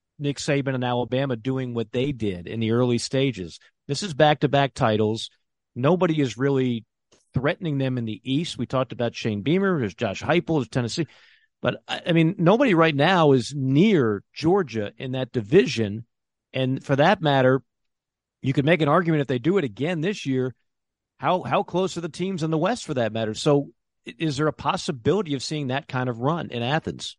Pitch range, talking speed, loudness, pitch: 125-165 Hz, 195 wpm, -23 LUFS, 140 Hz